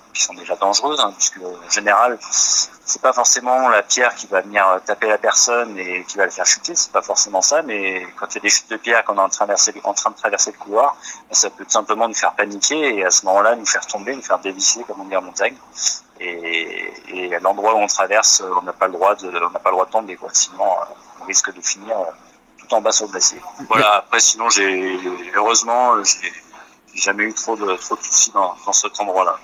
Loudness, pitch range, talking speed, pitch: -17 LUFS, 95-110 Hz, 240 wpm, 100 Hz